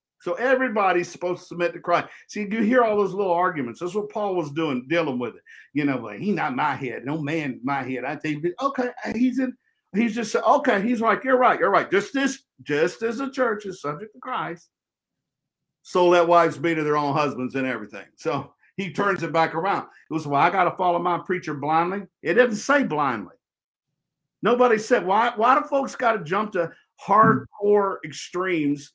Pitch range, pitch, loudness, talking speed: 155-225 Hz, 175 Hz, -23 LUFS, 205 wpm